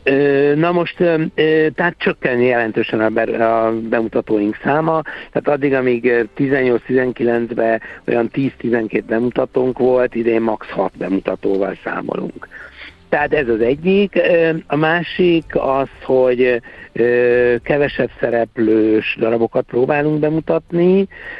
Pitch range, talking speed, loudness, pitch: 115-155 Hz, 95 wpm, -16 LUFS, 130 Hz